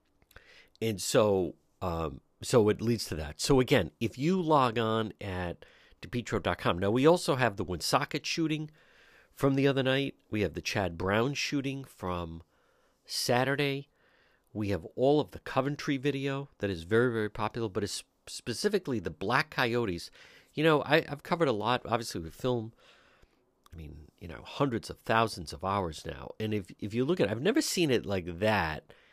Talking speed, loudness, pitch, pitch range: 175 wpm, -30 LUFS, 115 Hz, 95-140 Hz